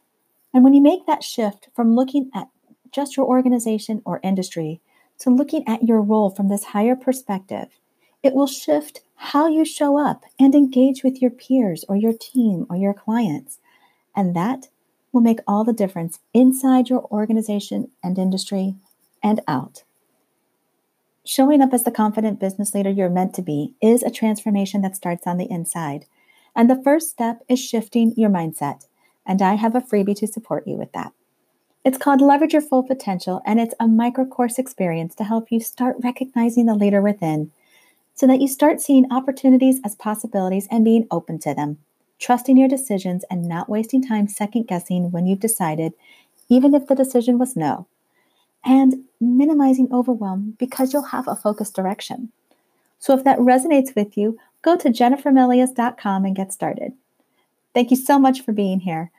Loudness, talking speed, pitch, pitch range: -19 LUFS, 175 wpm, 235 Hz, 200-260 Hz